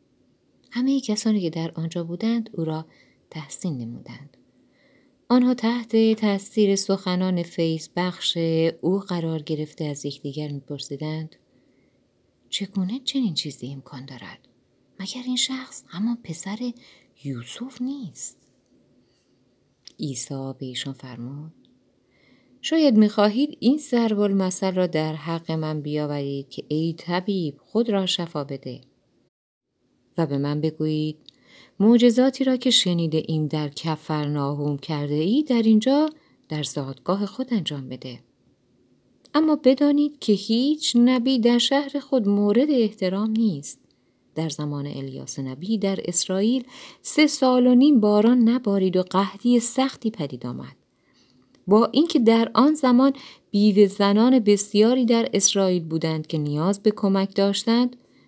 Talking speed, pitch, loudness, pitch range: 125 wpm, 190 Hz, -22 LUFS, 150-235 Hz